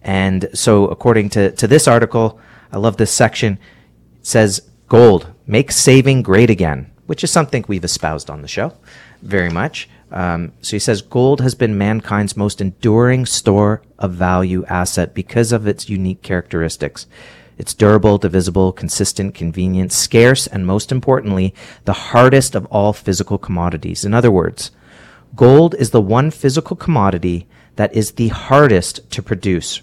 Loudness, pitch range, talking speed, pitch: -14 LUFS, 95-120 Hz, 155 wpm, 105 Hz